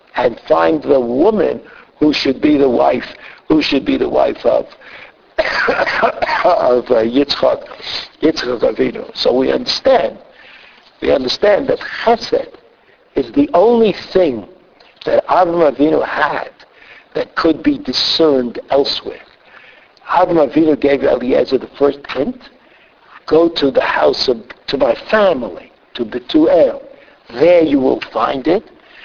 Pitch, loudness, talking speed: 175 Hz, -14 LUFS, 125 wpm